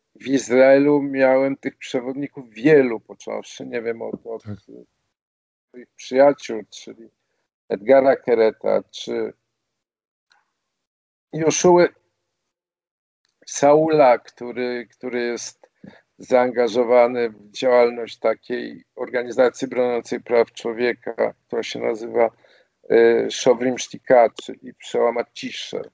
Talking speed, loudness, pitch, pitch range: 90 wpm, -19 LUFS, 125 Hz, 115-140 Hz